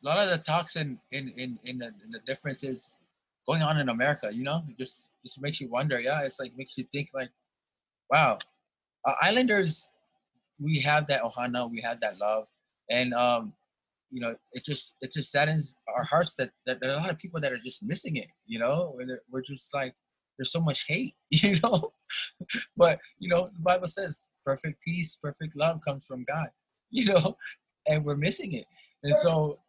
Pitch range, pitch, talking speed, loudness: 130-170 Hz, 145 Hz, 205 wpm, -29 LUFS